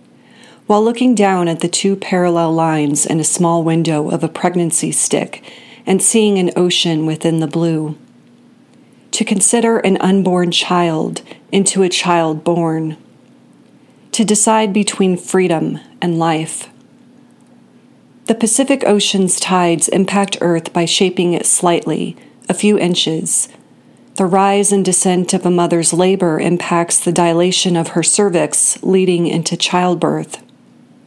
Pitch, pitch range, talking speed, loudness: 180 Hz, 170-205 Hz, 130 wpm, -14 LUFS